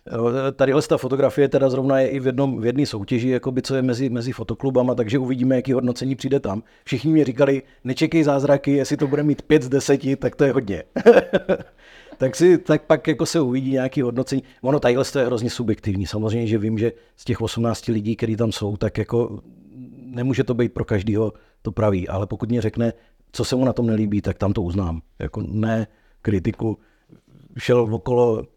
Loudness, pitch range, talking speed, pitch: -21 LUFS, 110-135 Hz, 200 wpm, 125 Hz